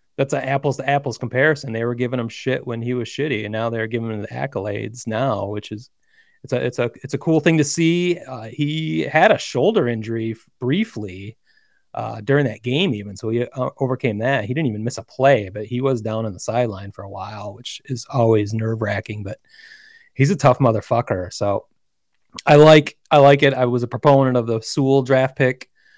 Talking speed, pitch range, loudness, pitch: 215 wpm, 110-140 Hz, -19 LUFS, 125 Hz